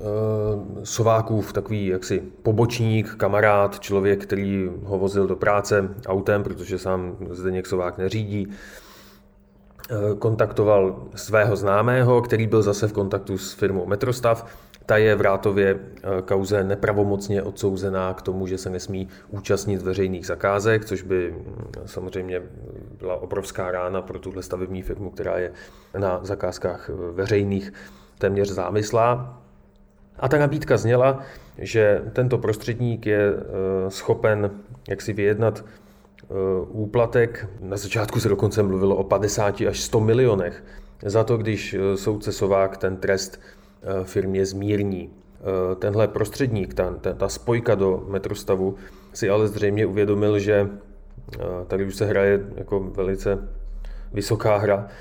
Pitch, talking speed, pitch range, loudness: 100 Hz, 120 wpm, 95-105 Hz, -23 LUFS